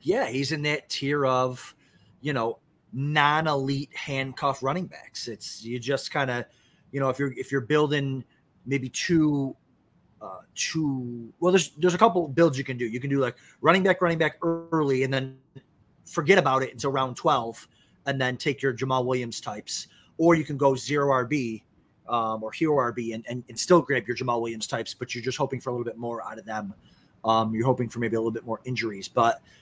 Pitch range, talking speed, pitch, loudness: 120-150 Hz, 210 wpm, 135 Hz, -26 LUFS